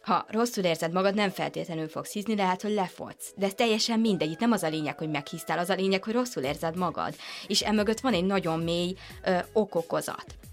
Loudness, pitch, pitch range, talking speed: -28 LUFS, 190 Hz, 165-215 Hz, 210 wpm